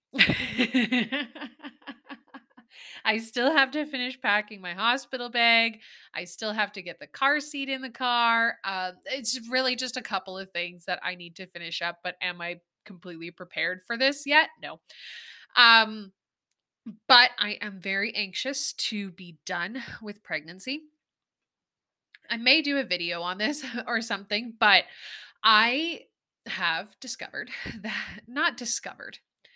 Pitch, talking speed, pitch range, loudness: 230 Hz, 140 wpm, 190-260 Hz, -25 LUFS